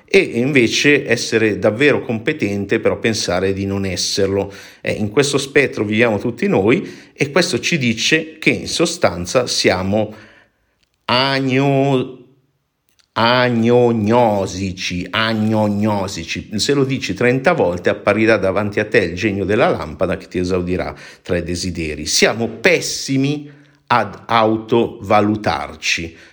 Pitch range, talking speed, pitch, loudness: 95-130 Hz, 115 wpm, 110 Hz, -17 LUFS